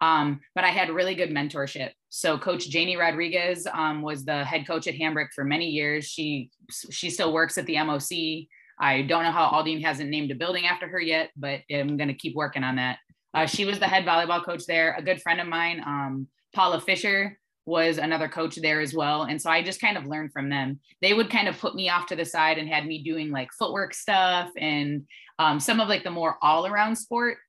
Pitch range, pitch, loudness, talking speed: 150-175 Hz, 160 Hz, -25 LUFS, 230 wpm